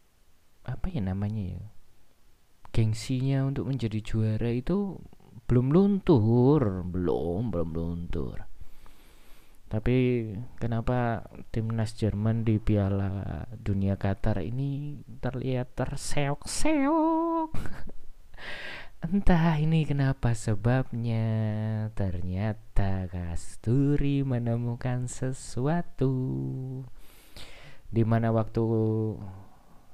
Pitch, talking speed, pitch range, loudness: 115 Hz, 70 wpm, 100-130 Hz, -29 LUFS